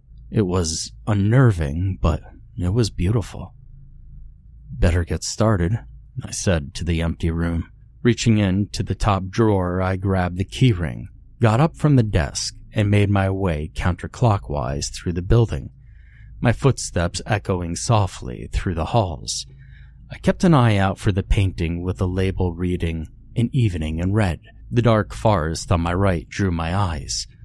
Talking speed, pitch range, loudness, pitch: 155 wpm, 85-115 Hz, -21 LUFS, 100 Hz